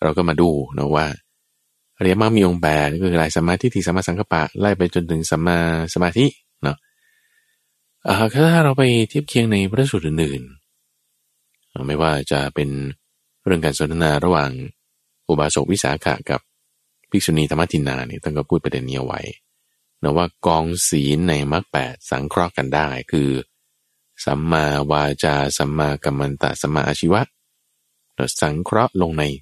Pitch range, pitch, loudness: 70-90 Hz, 80 Hz, -19 LUFS